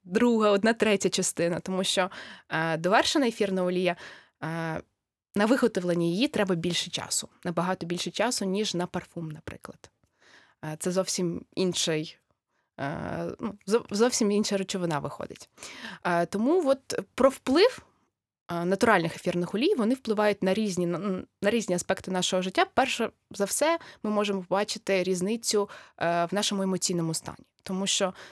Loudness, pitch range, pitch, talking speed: -27 LUFS, 175-215 Hz, 190 Hz, 125 wpm